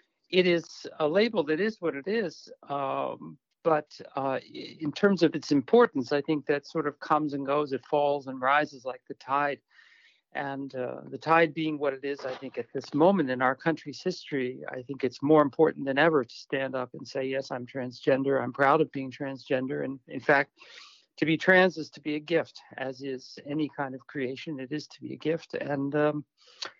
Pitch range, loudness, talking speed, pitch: 135-155 Hz, -28 LUFS, 210 wpm, 145 Hz